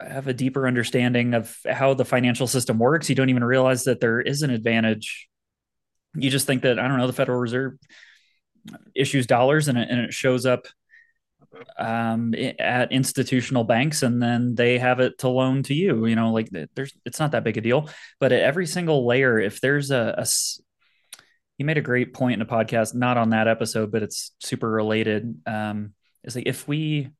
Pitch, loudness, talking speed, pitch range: 125 Hz, -22 LUFS, 200 wpm, 115-135 Hz